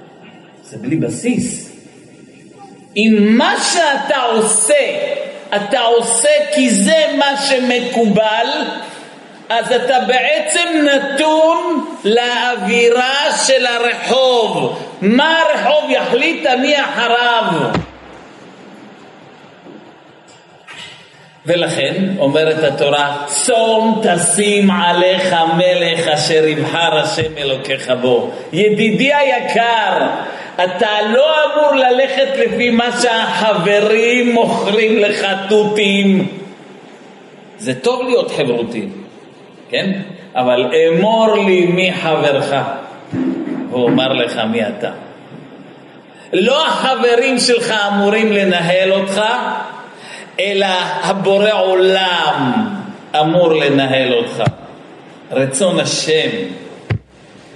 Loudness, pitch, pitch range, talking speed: -13 LUFS, 220 Hz, 185-245 Hz, 80 wpm